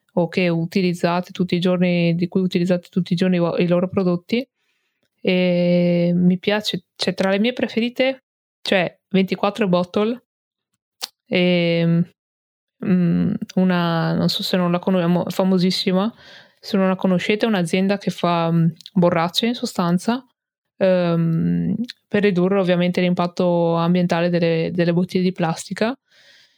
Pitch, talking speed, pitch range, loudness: 180 Hz, 120 wpm, 175-200 Hz, -20 LUFS